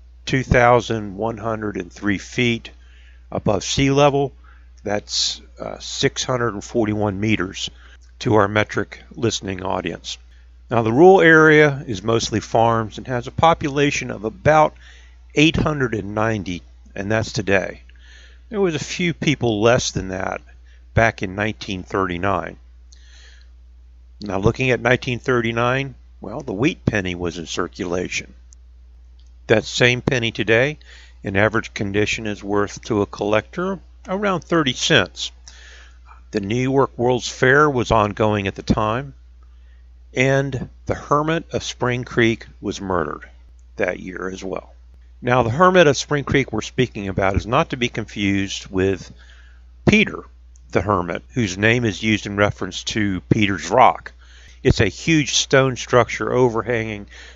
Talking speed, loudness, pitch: 130 wpm, -19 LUFS, 105 Hz